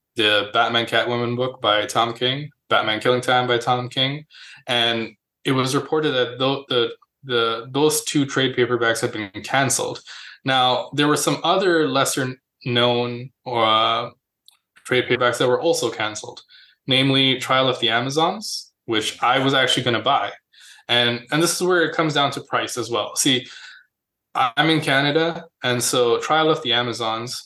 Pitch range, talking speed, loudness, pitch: 120-150 Hz, 165 wpm, -20 LUFS, 130 Hz